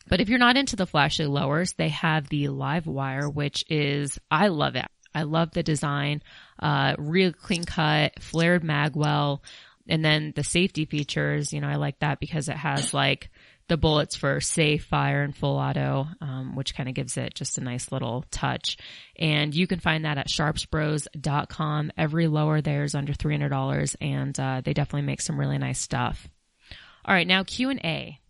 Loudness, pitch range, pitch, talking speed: -25 LUFS, 145-160 Hz, 150 Hz, 195 wpm